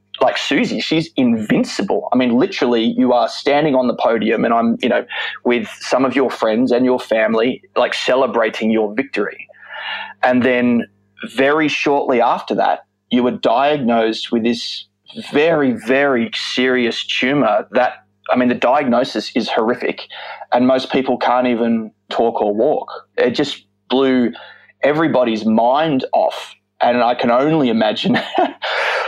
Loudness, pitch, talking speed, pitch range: -16 LUFS, 120 Hz, 145 wpm, 115-130 Hz